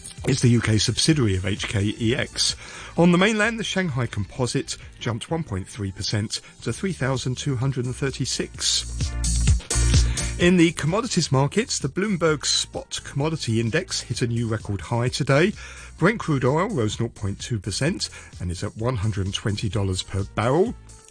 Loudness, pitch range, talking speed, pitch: -23 LUFS, 105-150 Hz, 120 wpm, 120 Hz